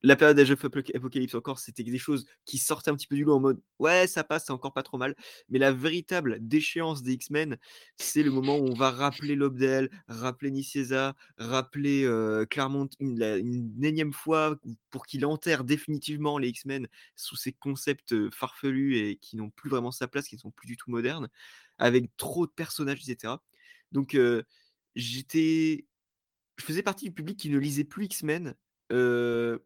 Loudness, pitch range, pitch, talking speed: -29 LUFS, 125-150 Hz, 135 Hz, 185 wpm